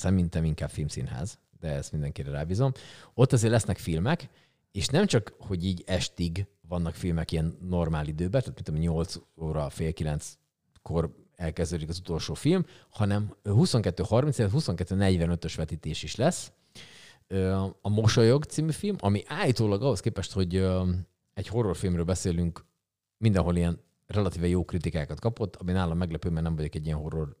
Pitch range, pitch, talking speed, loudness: 80-110 Hz, 90 Hz, 140 wpm, -29 LUFS